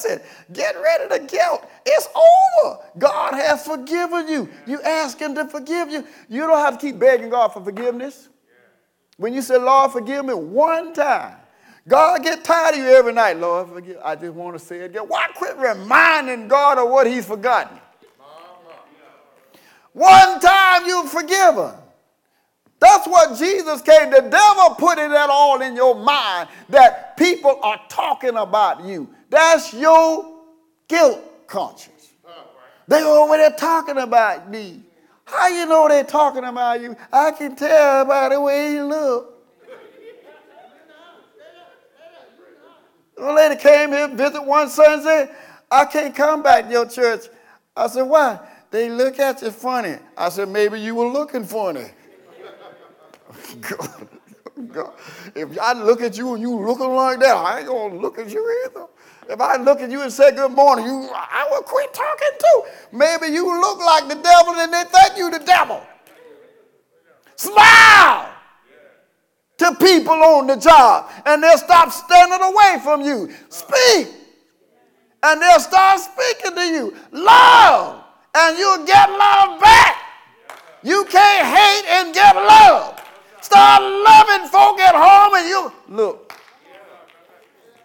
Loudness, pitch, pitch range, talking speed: -14 LUFS, 310 Hz, 265-365 Hz, 150 wpm